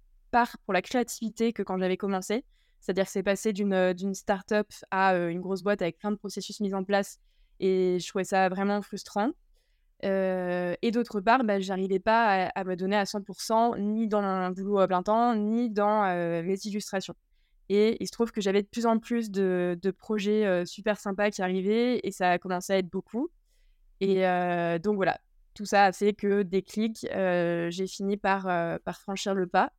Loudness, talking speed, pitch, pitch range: -28 LUFS, 205 wpm, 200 Hz, 185-210 Hz